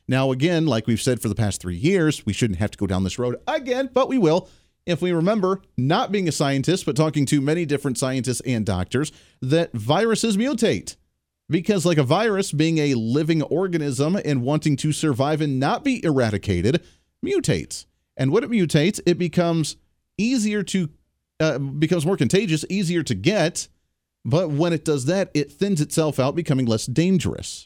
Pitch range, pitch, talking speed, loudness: 130-175 Hz, 155 Hz, 180 wpm, -22 LUFS